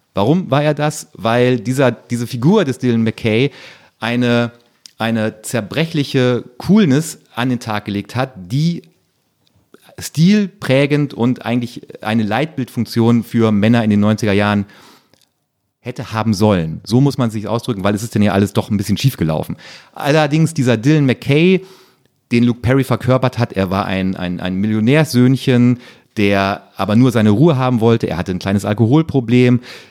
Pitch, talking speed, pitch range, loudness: 120 Hz, 155 wpm, 105-135 Hz, -15 LUFS